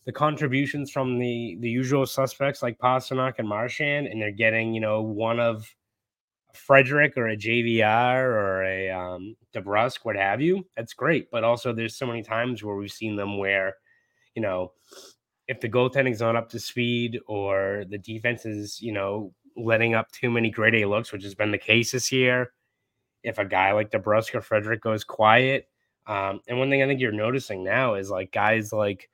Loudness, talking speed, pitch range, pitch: -24 LUFS, 190 wpm, 105-125 Hz, 115 Hz